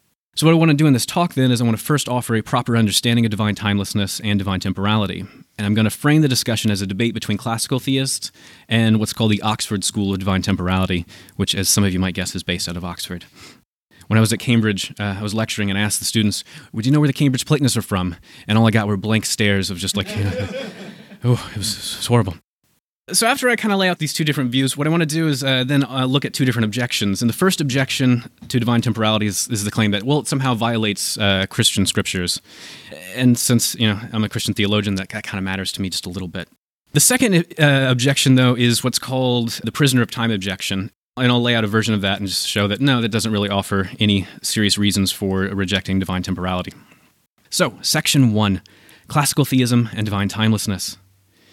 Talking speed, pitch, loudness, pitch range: 240 wpm, 110 Hz, -18 LUFS, 100-130 Hz